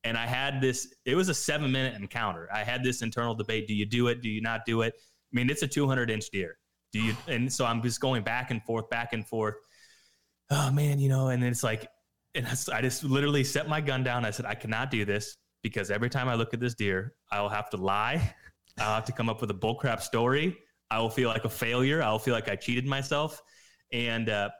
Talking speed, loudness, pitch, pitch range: 245 wpm, -30 LUFS, 120 Hz, 110-130 Hz